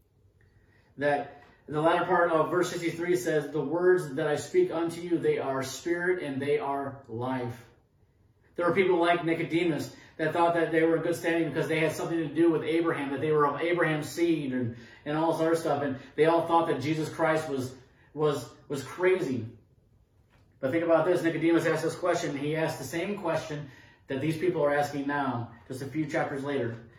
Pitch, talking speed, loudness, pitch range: 155 Hz, 200 wpm, -28 LUFS, 135-165 Hz